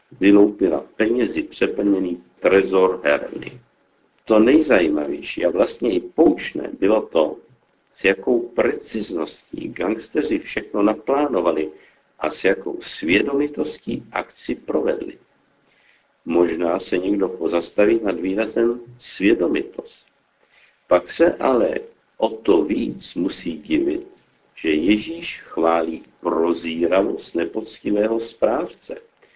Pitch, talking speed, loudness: 110 Hz, 95 wpm, -20 LUFS